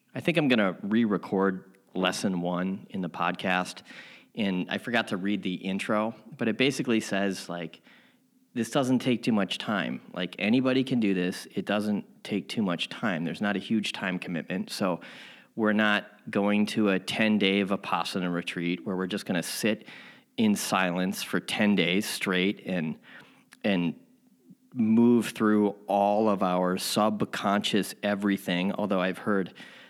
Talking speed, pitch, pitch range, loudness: 160 wpm, 100 Hz, 95-110 Hz, -28 LUFS